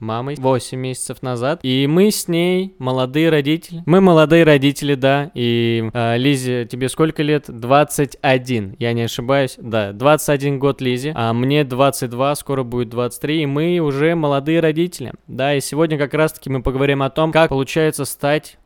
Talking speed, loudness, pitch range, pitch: 165 wpm, -17 LUFS, 130-155 Hz, 140 Hz